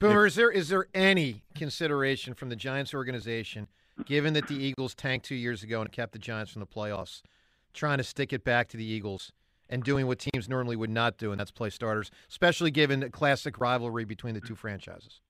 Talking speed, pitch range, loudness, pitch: 215 wpm, 110-140 Hz, -30 LUFS, 125 Hz